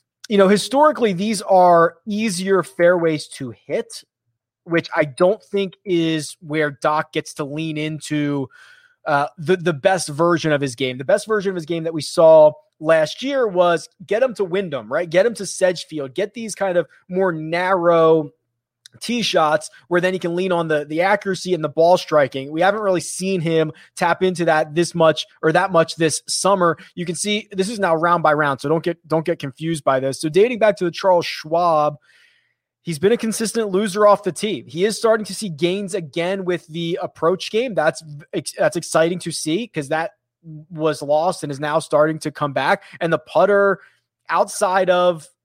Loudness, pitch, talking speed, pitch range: -19 LUFS, 170 Hz, 195 wpm, 155-190 Hz